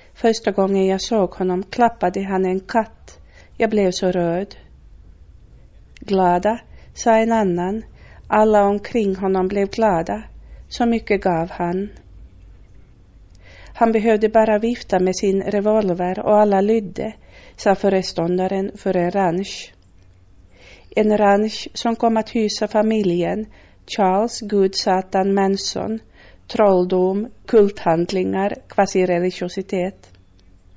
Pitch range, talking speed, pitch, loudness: 175-215 Hz, 105 wpm, 195 Hz, -19 LUFS